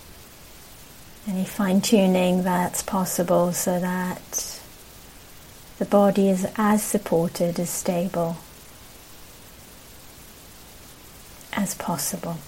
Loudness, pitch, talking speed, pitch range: -23 LUFS, 185 Hz, 75 wpm, 175-200 Hz